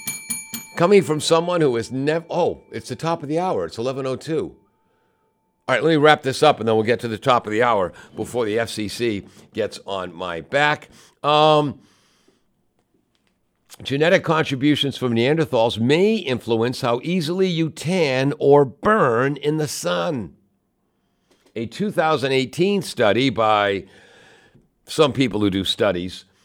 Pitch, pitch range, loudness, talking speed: 135 Hz, 115-155 Hz, -20 LUFS, 145 wpm